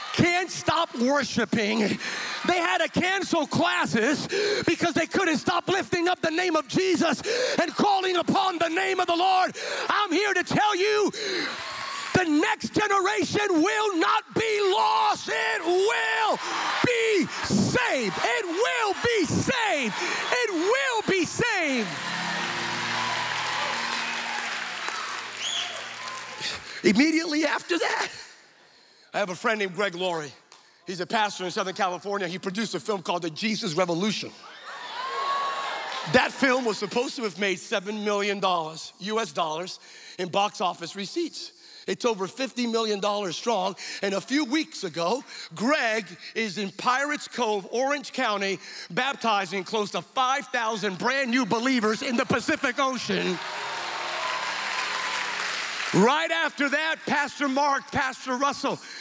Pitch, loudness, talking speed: 275 Hz, -25 LUFS, 125 wpm